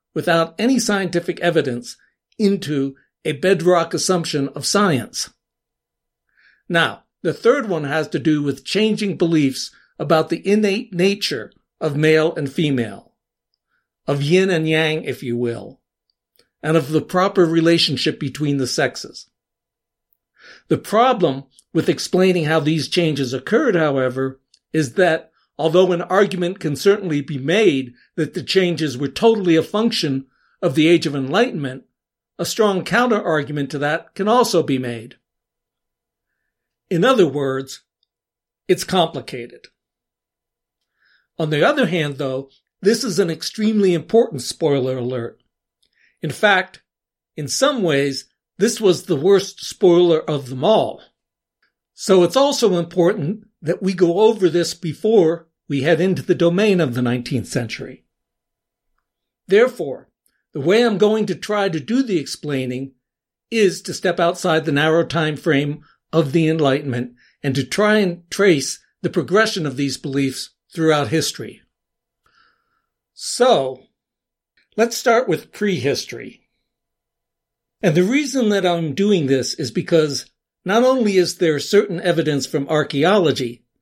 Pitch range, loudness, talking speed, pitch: 145-195 Hz, -18 LUFS, 135 wpm, 165 Hz